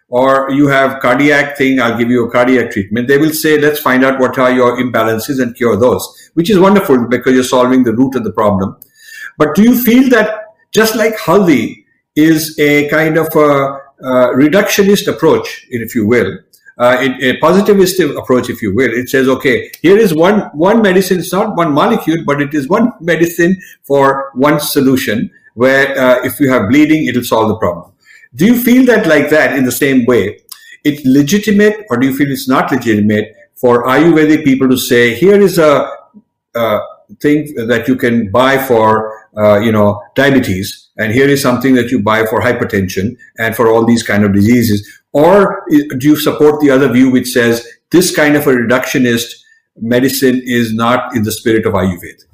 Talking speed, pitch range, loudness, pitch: 190 wpm, 125-160 Hz, -11 LUFS, 135 Hz